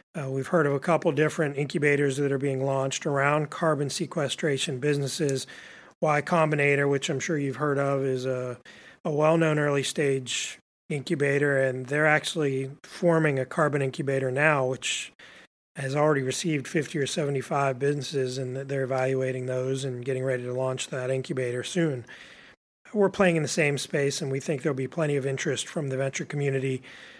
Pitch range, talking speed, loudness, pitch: 135-155 Hz, 170 wpm, -26 LUFS, 140 Hz